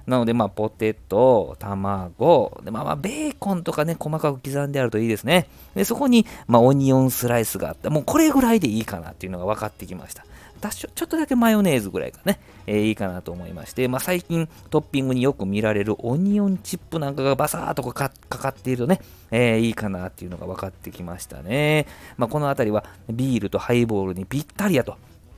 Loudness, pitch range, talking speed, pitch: -22 LUFS, 100-150 Hz, 465 characters per minute, 120 Hz